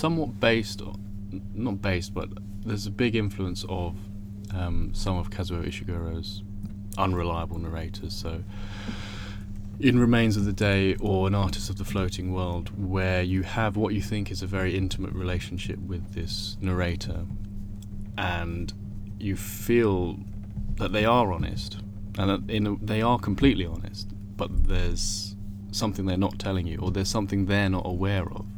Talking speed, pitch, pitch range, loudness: 155 wpm, 100 Hz, 95-100 Hz, -28 LUFS